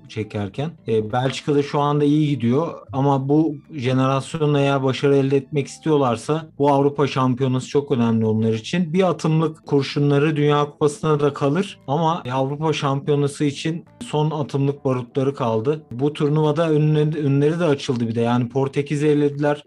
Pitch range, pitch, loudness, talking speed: 135-150 Hz, 145 Hz, -20 LUFS, 140 wpm